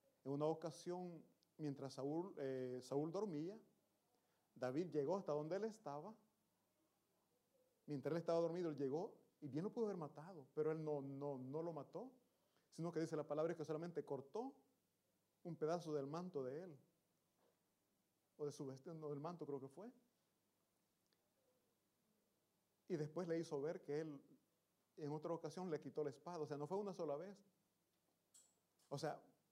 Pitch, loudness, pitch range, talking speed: 155 Hz, -48 LUFS, 145-180 Hz, 165 wpm